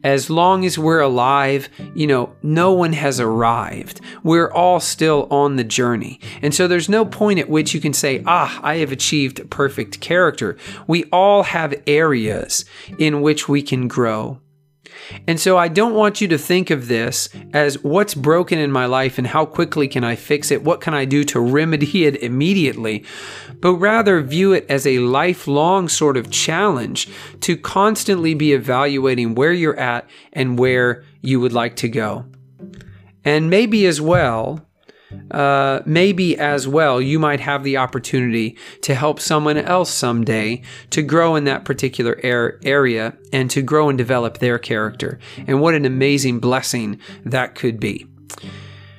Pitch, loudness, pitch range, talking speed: 140 Hz, -17 LUFS, 125-160 Hz, 170 wpm